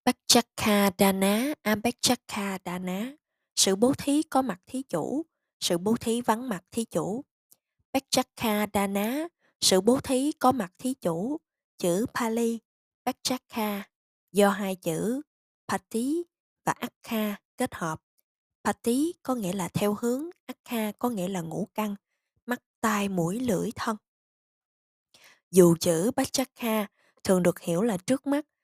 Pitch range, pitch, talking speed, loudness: 195-255 Hz, 230 Hz, 135 wpm, -27 LUFS